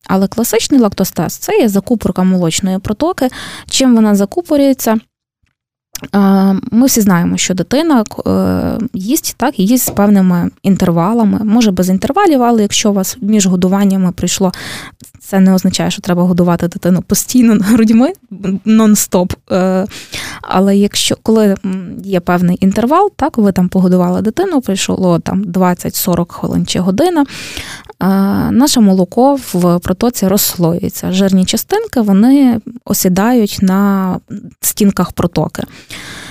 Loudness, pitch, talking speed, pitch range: -12 LUFS, 195 Hz, 115 wpm, 185-230 Hz